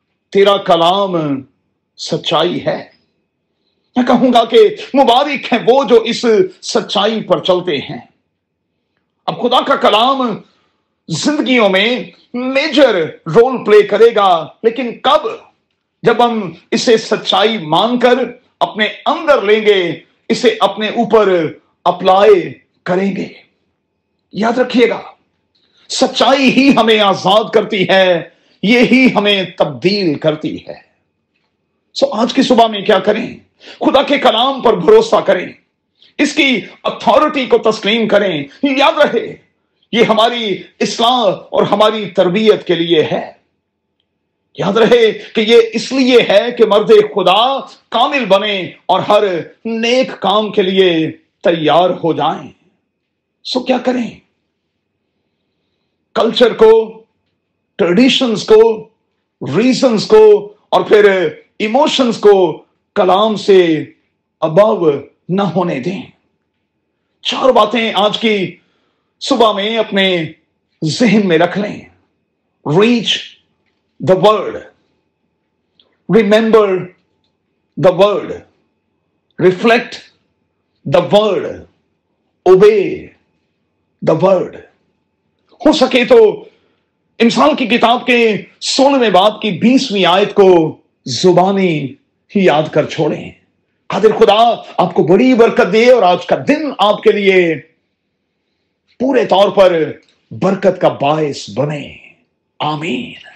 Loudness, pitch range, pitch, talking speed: -12 LUFS, 185-250 Hz, 215 Hz, 110 wpm